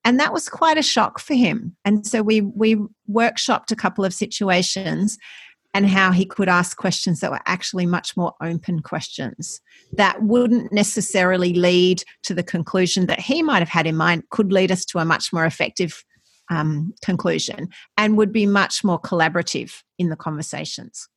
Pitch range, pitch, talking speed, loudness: 175-215 Hz, 190 Hz, 180 wpm, -20 LUFS